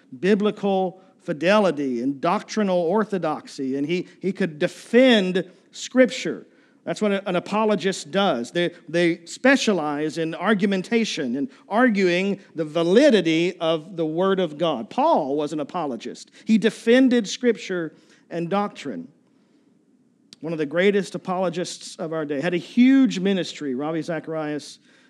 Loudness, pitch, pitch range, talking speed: -22 LUFS, 185 Hz, 165-220 Hz, 125 wpm